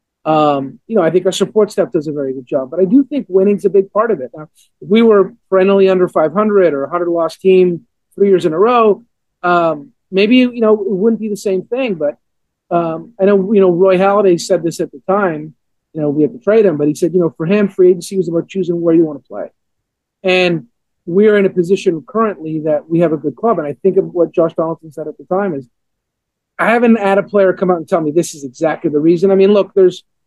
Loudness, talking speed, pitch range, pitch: -13 LUFS, 260 wpm, 160-200 Hz, 185 Hz